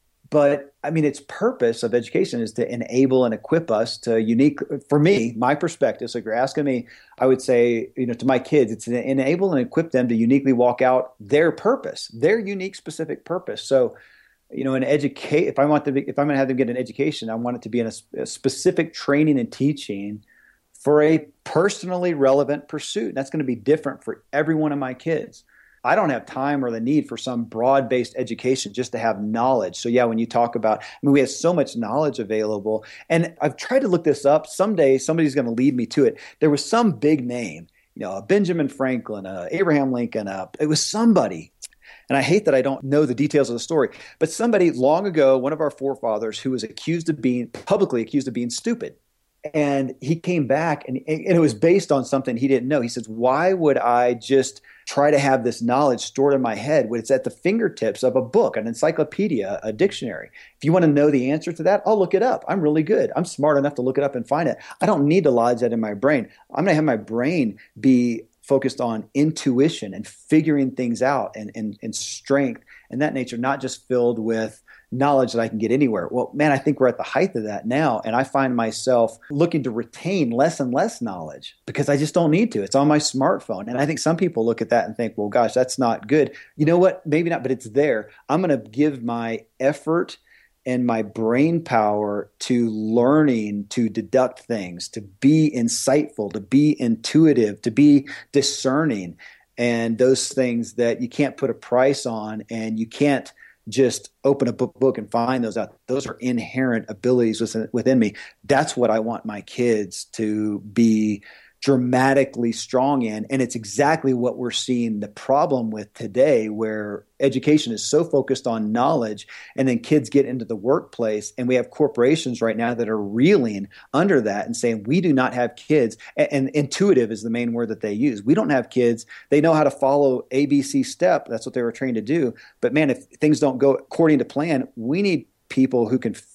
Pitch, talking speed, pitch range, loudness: 130 Hz, 220 wpm, 115-150 Hz, -21 LUFS